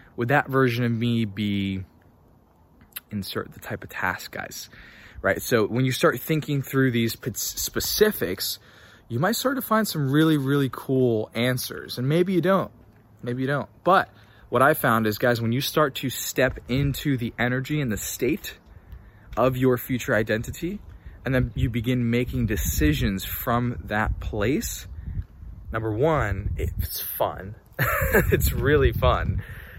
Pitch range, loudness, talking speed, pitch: 100-130 Hz, -24 LUFS, 150 wpm, 120 Hz